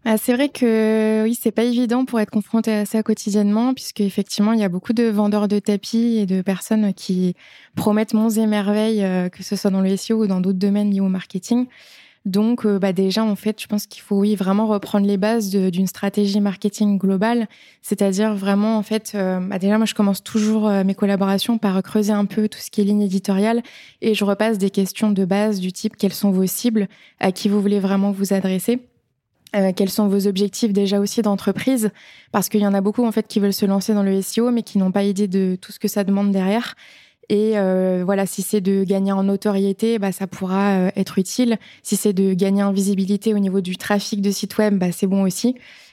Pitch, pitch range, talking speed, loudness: 205 Hz, 195-220 Hz, 225 wpm, -19 LUFS